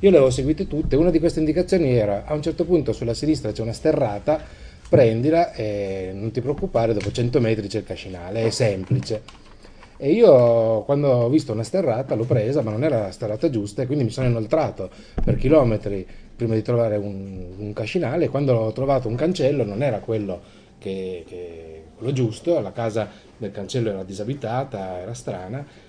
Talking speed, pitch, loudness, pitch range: 190 wpm, 115 Hz, -22 LUFS, 105-140 Hz